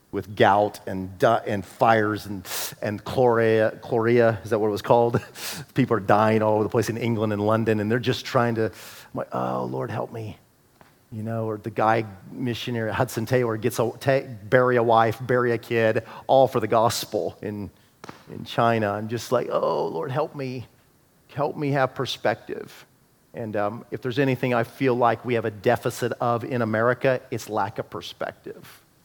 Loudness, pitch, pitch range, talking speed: -24 LUFS, 115 Hz, 110-125 Hz, 190 wpm